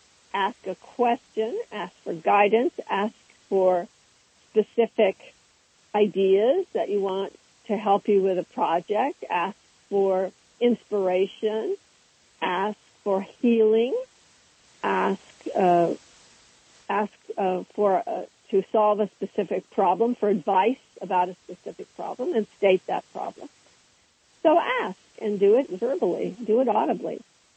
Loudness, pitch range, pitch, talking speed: -25 LUFS, 190-230 Hz, 205 Hz, 120 wpm